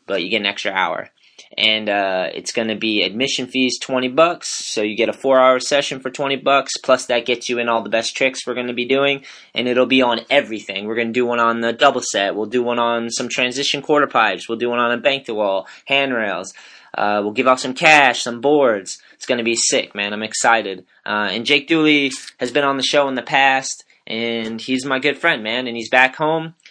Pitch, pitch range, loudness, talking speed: 125 Hz, 115-135 Hz, -17 LUFS, 235 wpm